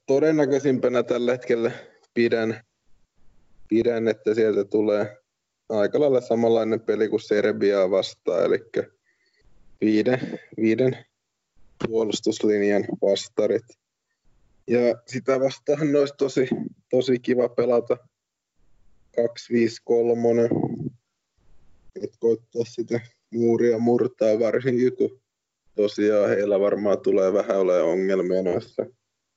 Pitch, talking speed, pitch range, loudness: 115 Hz, 90 wpm, 110-130 Hz, -23 LUFS